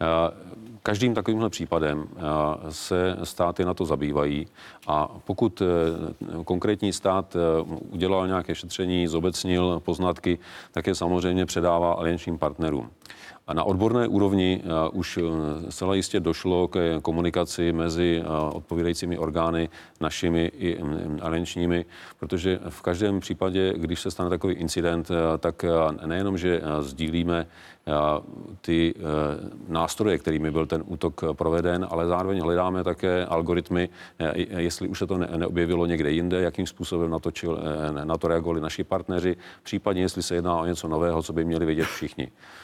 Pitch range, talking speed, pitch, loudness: 80-90 Hz, 125 wpm, 85 Hz, -26 LUFS